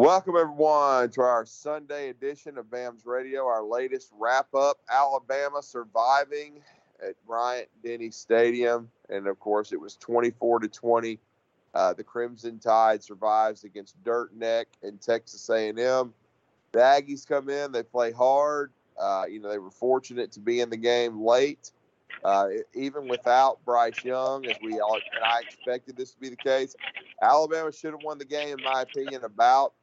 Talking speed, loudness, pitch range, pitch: 165 wpm, -26 LUFS, 115-140 Hz, 125 Hz